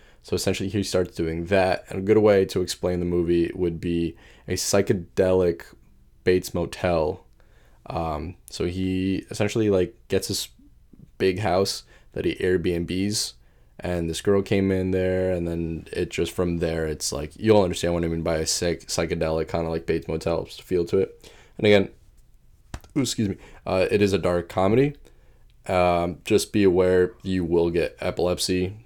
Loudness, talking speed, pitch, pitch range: -24 LUFS, 170 wpm, 90 Hz, 85-95 Hz